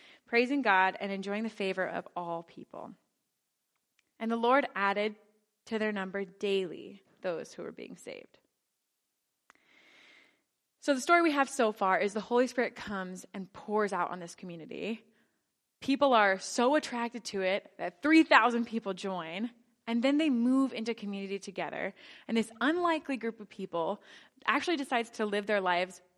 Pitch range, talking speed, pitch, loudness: 195-250 Hz, 160 wpm, 215 Hz, -31 LUFS